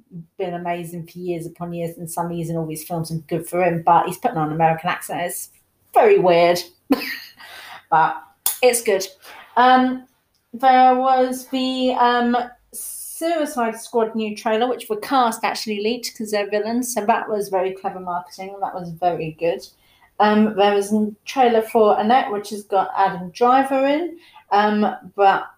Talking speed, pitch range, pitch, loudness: 165 wpm, 175-245 Hz, 205 Hz, -20 LUFS